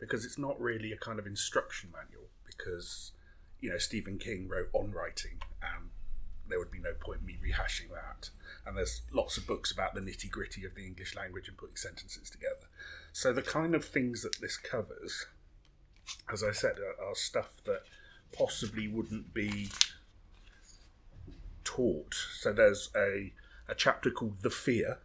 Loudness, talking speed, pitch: -36 LUFS, 170 wpm, 105 Hz